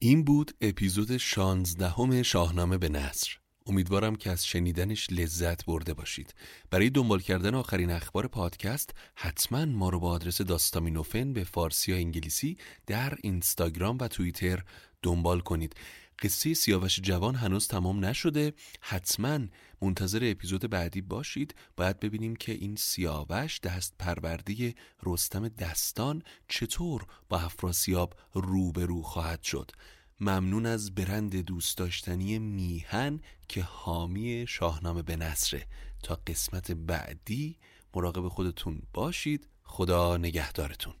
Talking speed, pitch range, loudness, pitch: 120 wpm, 85-110 Hz, -31 LUFS, 95 Hz